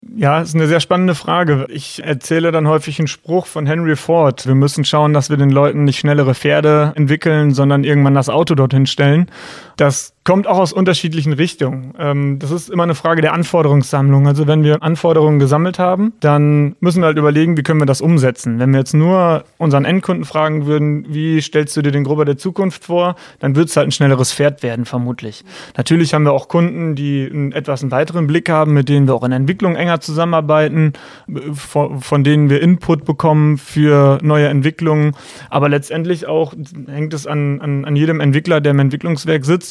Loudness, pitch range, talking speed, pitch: -14 LUFS, 145-165 Hz, 200 wpm, 150 Hz